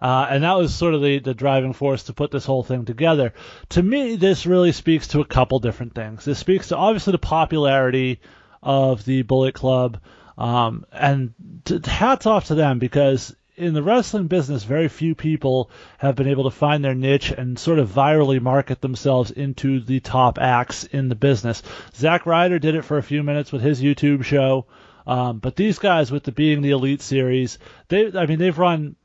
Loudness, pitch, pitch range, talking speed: -20 LUFS, 140 Hz, 130-160 Hz, 200 wpm